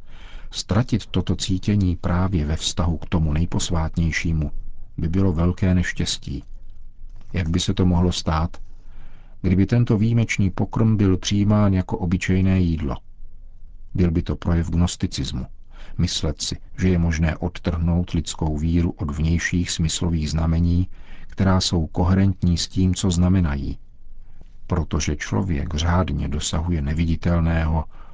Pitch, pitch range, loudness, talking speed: 90 Hz, 80-95 Hz, -22 LUFS, 120 wpm